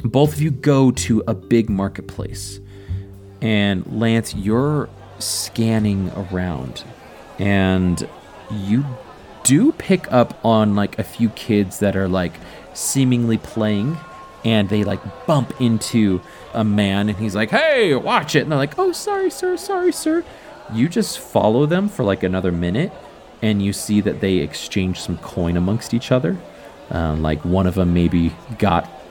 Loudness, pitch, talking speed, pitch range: -19 LUFS, 105 Hz, 155 wpm, 95-120 Hz